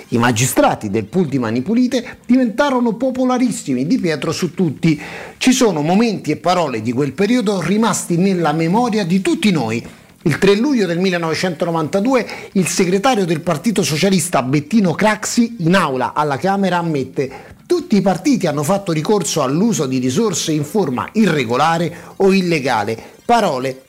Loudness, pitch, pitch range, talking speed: -16 LUFS, 185 Hz, 155-220 Hz, 145 wpm